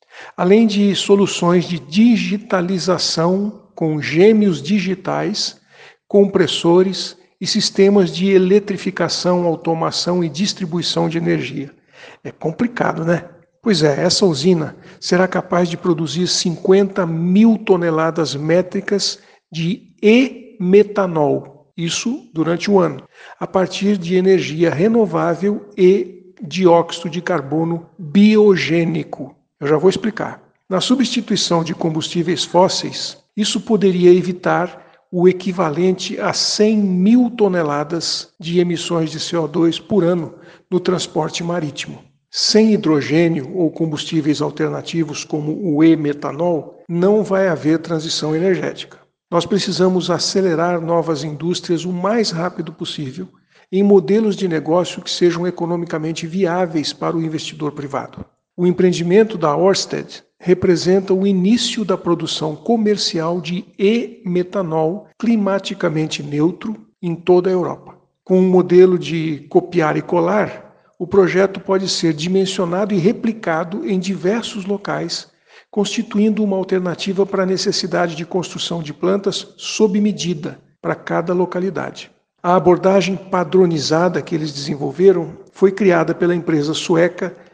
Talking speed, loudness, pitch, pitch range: 120 wpm, -17 LUFS, 180 Hz, 165-195 Hz